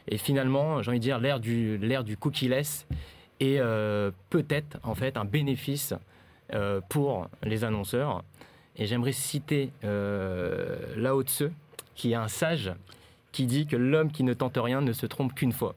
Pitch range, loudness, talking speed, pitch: 110-140 Hz, -29 LUFS, 175 wpm, 130 Hz